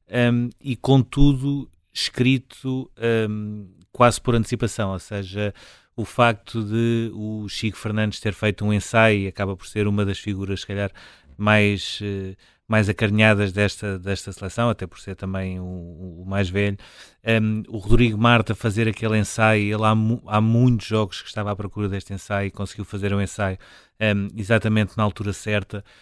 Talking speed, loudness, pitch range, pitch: 170 wpm, -22 LUFS, 100-115 Hz, 105 Hz